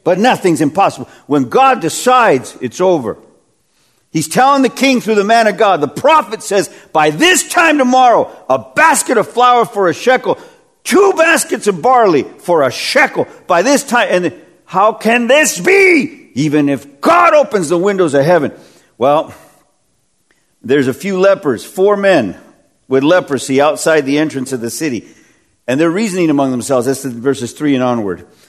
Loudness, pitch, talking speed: -12 LUFS, 210 Hz, 170 wpm